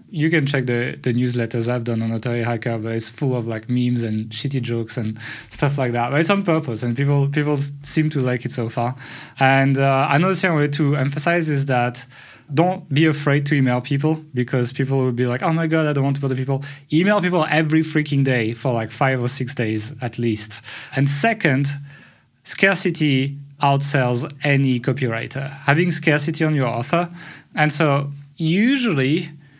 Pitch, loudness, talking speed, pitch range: 140 Hz, -20 LUFS, 190 wpm, 125-155 Hz